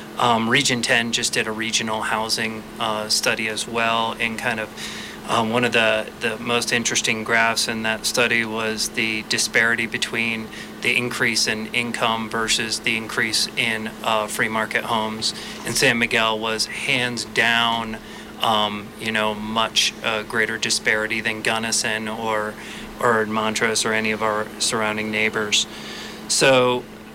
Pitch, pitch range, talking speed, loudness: 110 Hz, 110-115 Hz, 150 wpm, -20 LUFS